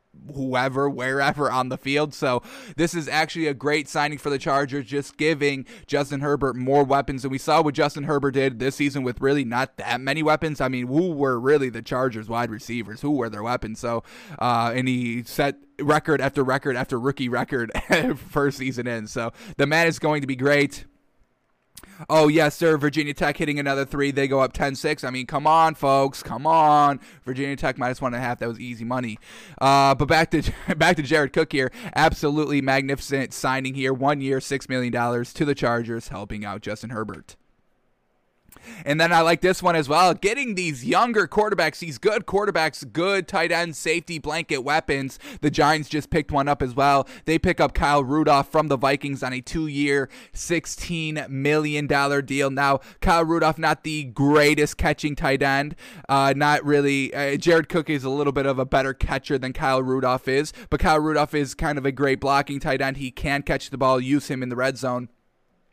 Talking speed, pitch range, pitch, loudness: 200 wpm, 130-155 Hz, 140 Hz, -22 LUFS